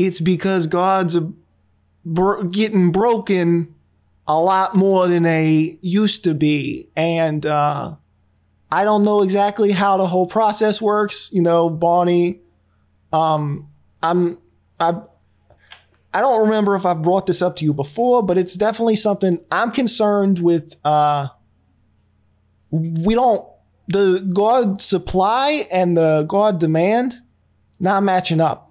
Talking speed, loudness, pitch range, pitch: 130 wpm, -17 LUFS, 155-200 Hz, 175 Hz